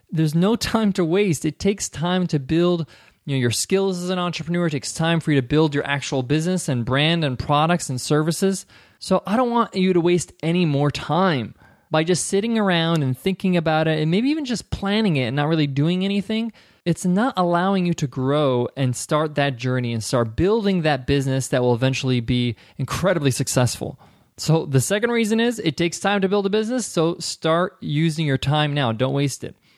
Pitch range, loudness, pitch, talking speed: 140-185 Hz, -21 LUFS, 160 Hz, 210 wpm